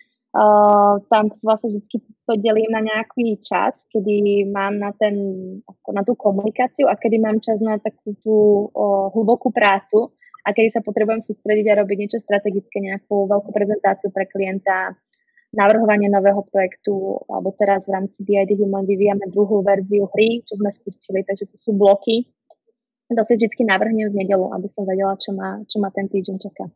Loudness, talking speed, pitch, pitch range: -19 LUFS, 170 wpm, 205 Hz, 200-220 Hz